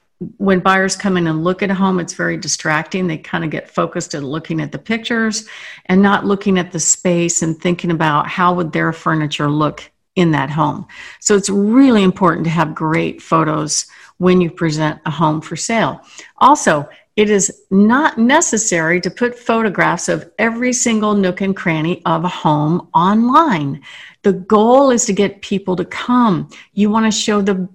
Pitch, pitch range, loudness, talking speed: 185 Hz, 165-210 Hz, -15 LUFS, 185 wpm